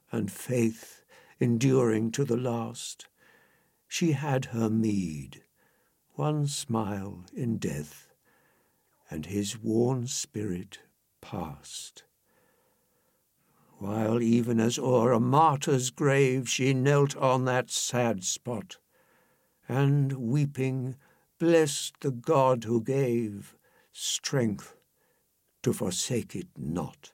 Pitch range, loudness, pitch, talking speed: 110-140 Hz, -28 LUFS, 125 Hz, 95 wpm